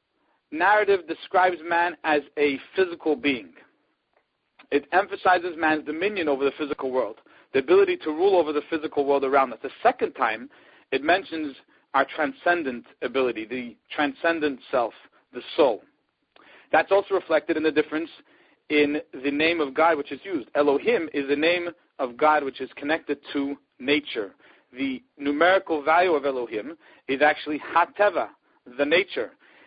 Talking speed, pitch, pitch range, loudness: 150 wpm, 155 Hz, 145-175 Hz, -24 LUFS